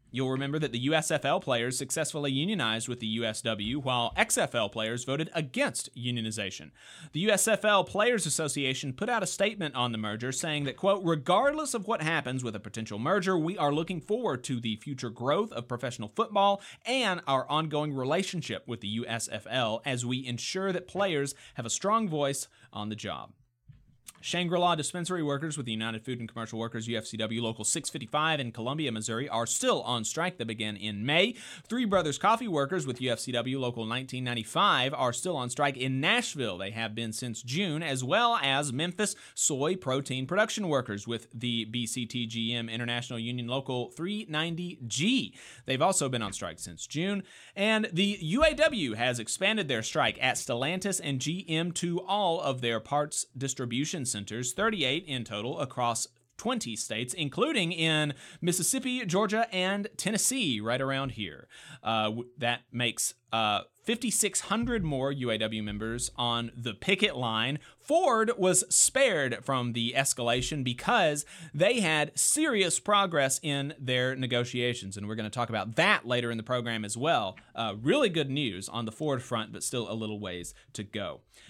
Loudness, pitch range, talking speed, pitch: -29 LUFS, 120-175 Hz, 165 wpm, 135 Hz